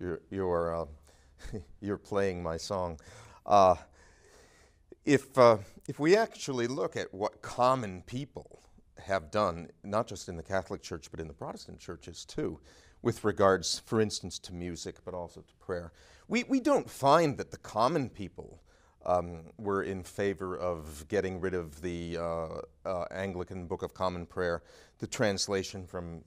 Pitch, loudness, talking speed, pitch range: 95 Hz, -32 LUFS, 160 wpm, 85-105 Hz